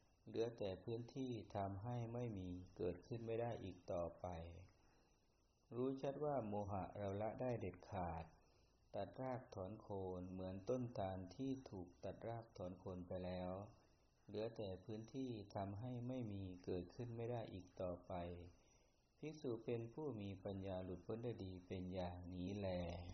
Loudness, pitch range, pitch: -50 LUFS, 90-115 Hz, 100 Hz